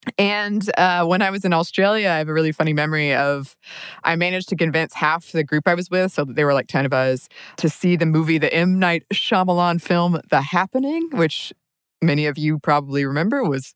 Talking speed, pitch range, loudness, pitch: 220 wpm, 150-185 Hz, -19 LUFS, 165 Hz